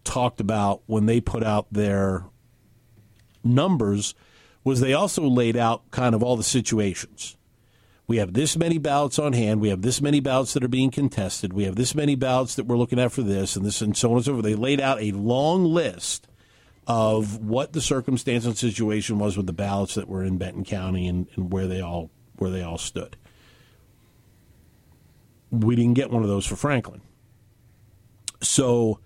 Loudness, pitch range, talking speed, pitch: -23 LUFS, 100-125 Hz, 190 wpm, 115 Hz